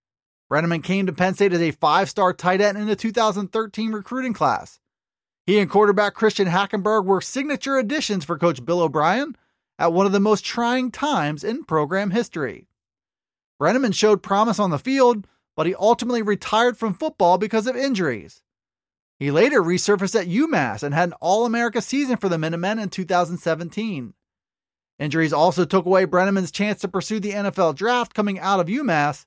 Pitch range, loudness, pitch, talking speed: 175-225 Hz, -21 LUFS, 200 Hz, 170 wpm